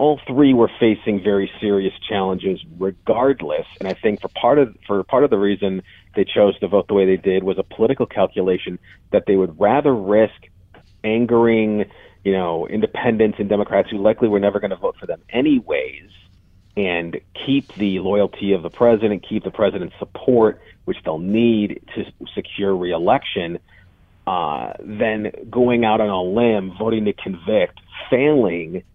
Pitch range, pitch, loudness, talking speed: 95-115 Hz, 100 Hz, -19 LUFS, 165 wpm